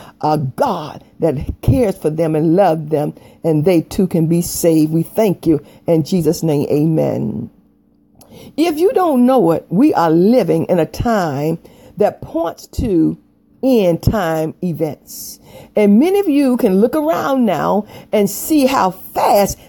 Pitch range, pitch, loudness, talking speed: 160-235 Hz, 175 Hz, -15 LUFS, 155 wpm